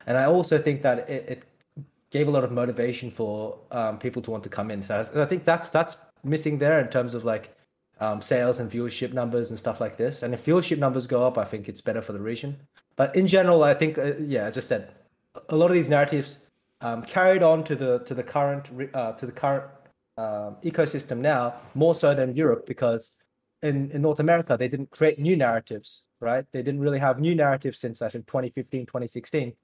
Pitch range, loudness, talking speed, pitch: 120-155 Hz, -25 LUFS, 220 wpm, 135 Hz